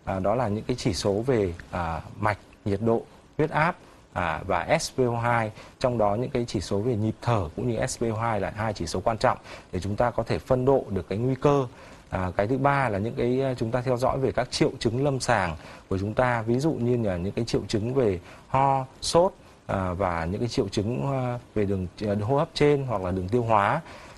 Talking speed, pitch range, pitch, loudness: 230 wpm, 100-130 Hz, 115 Hz, -26 LUFS